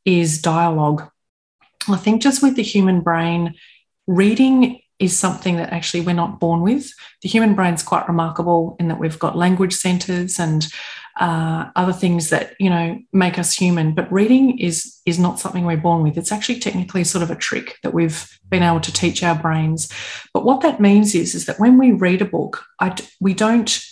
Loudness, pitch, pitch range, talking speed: -17 LUFS, 180 Hz, 170-210 Hz, 195 wpm